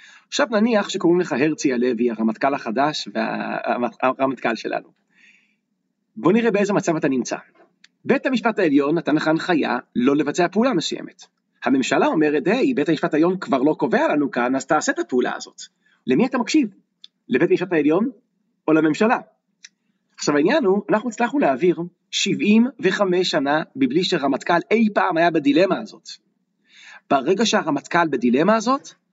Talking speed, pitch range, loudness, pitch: 145 wpm, 155-220 Hz, -20 LUFS, 190 Hz